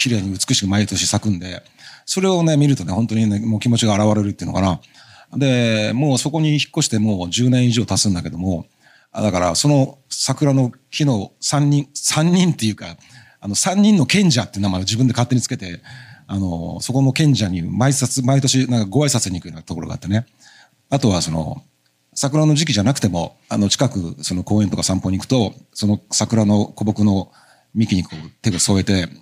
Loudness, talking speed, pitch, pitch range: -18 LUFS, 365 characters per minute, 115 Hz, 100-135 Hz